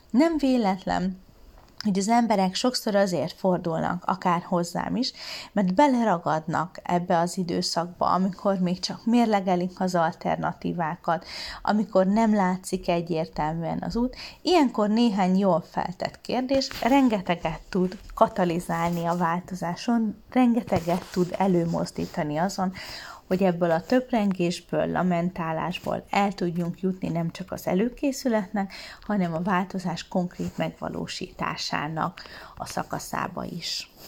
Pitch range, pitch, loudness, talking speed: 175-220 Hz, 185 Hz, -26 LUFS, 110 wpm